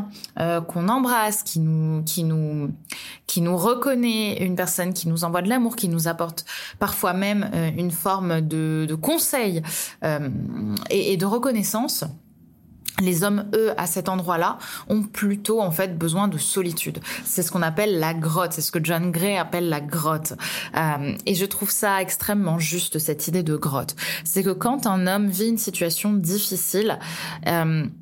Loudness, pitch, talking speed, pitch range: -23 LUFS, 180 Hz, 175 wpm, 165-205 Hz